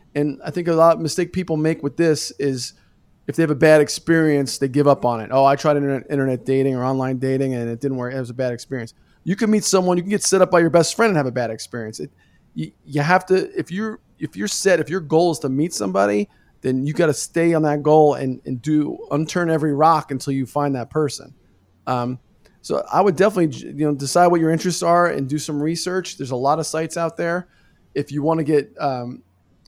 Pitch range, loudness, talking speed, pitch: 130-170 Hz, -19 LUFS, 250 wpm, 150 Hz